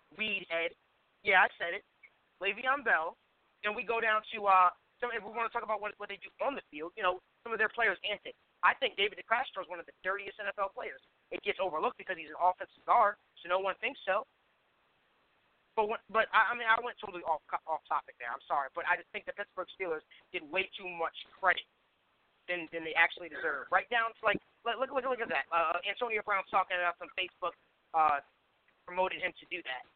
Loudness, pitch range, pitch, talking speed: -33 LUFS, 180-225 Hz, 195 Hz, 225 wpm